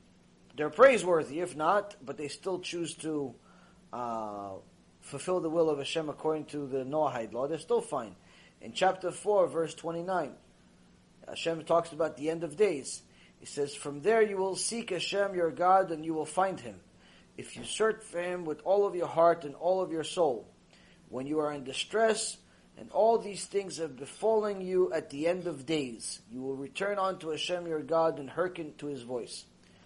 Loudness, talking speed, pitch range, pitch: -31 LUFS, 190 wpm, 145-185 Hz, 165 Hz